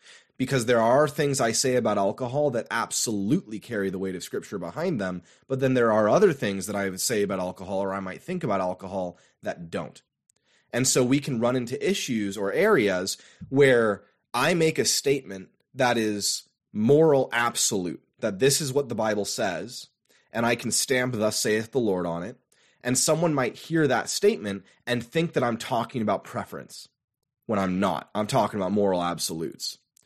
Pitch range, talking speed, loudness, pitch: 100-140 Hz, 185 wpm, -25 LUFS, 120 Hz